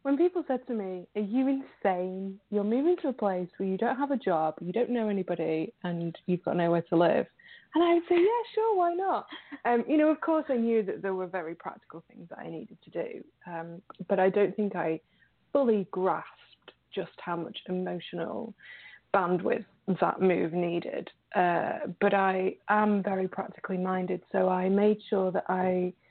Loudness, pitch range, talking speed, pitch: -29 LUFS, 180-250 Hz, 195 wpm, 195 Hz